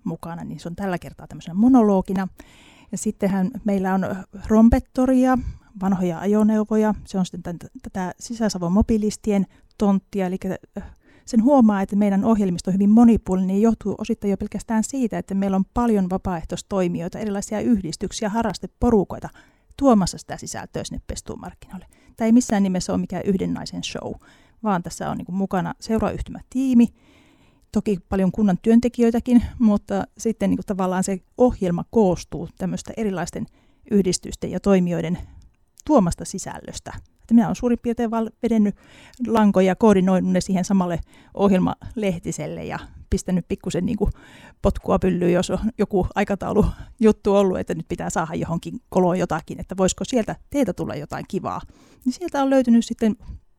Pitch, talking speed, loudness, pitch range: 200 Hz, 140 wpm, -21 LUFS, 185-225 Hz